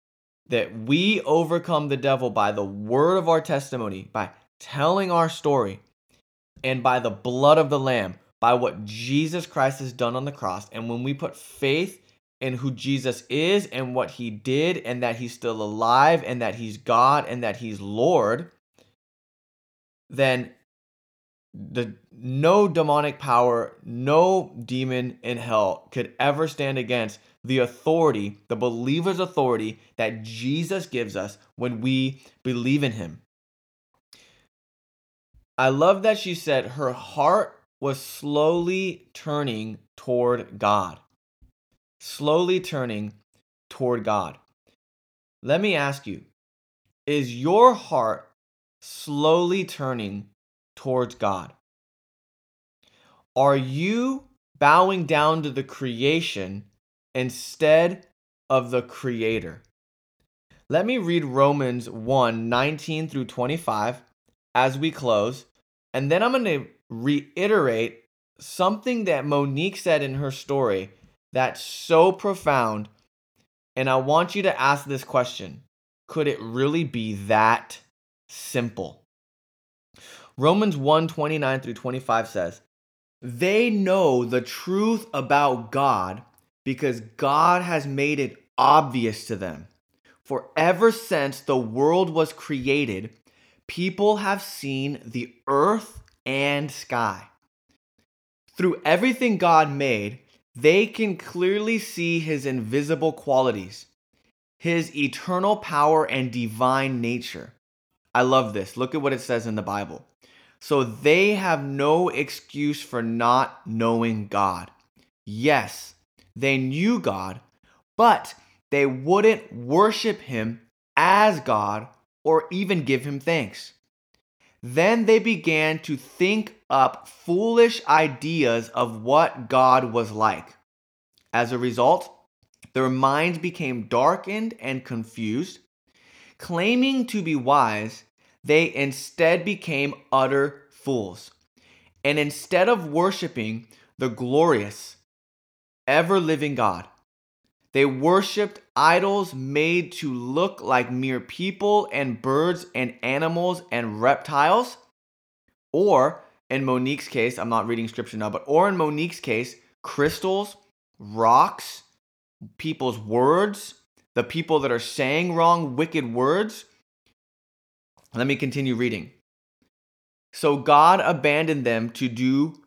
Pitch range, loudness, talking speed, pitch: 115-160 Hz, -23 LUFS, 120 wpm, 135 Hz